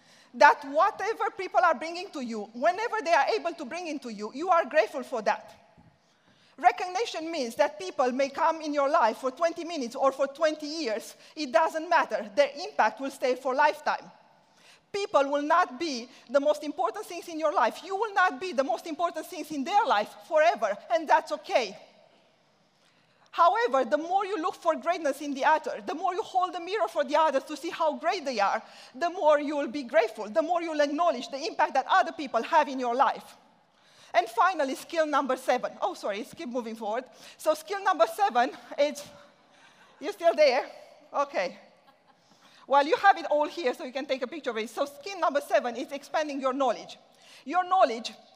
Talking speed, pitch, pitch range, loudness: 200 wpm, 310 Hz, 275-345 Hz, -27 LUFS